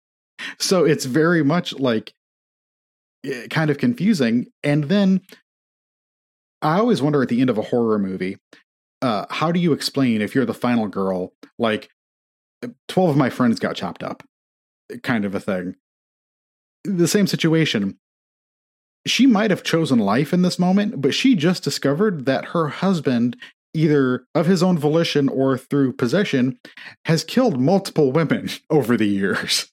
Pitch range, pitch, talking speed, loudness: 125-180 Hz, 150 Hz, 150 wpm, -20 LUFS